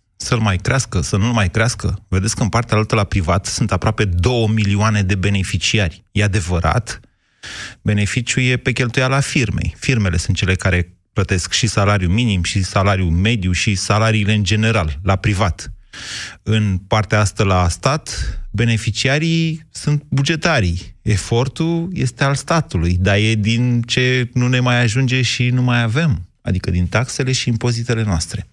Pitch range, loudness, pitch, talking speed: 95-125 Hz, -17 LUFS, 110 Hz, 160 wpm